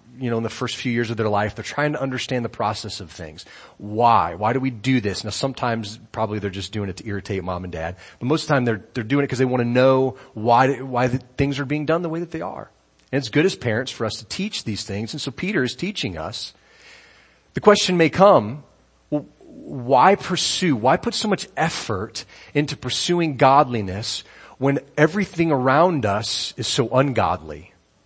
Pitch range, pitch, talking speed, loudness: 105-145 Hz, 125 Hz, 215 wpm, -21 LUFS